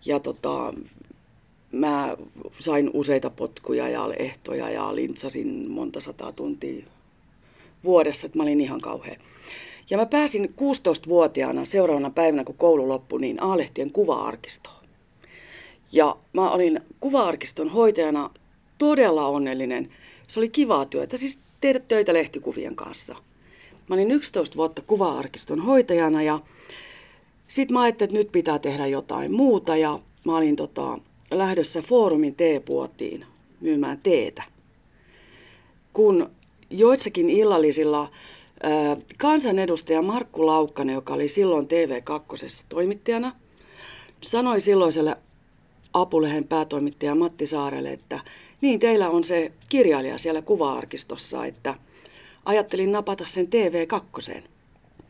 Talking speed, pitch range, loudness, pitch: 110 wpm, 150-250 Hz, -23 LUFS, 175 Hz